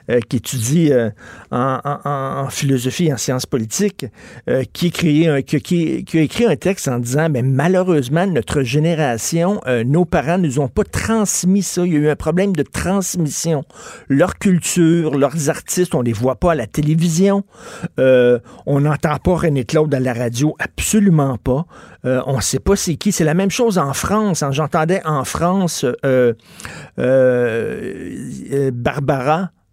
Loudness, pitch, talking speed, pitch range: -17 LUFS, 155 Hz, 180 wpm, 135-175 Hz